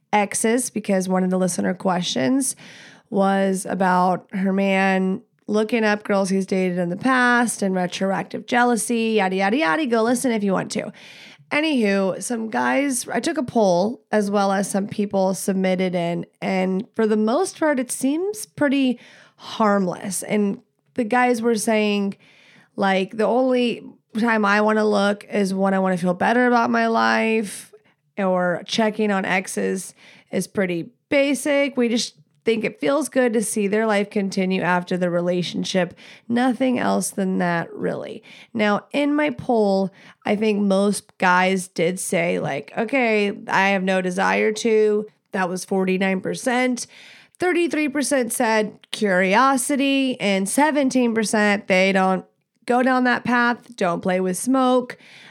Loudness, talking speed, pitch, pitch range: -21 LUFS, 150 wpm, 210 Hz, 190-240 Hz